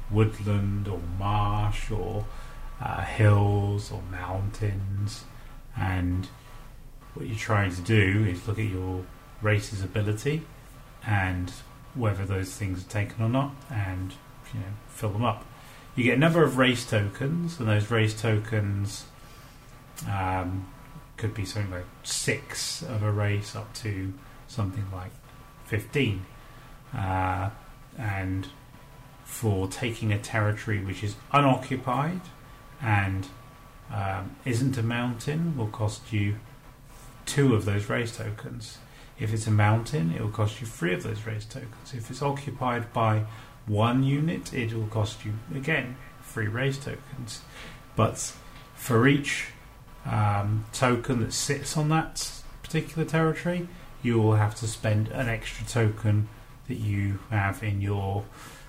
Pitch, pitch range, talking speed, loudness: 115 Hz, 105-130 Hz, 135 wpm, -28 LUFS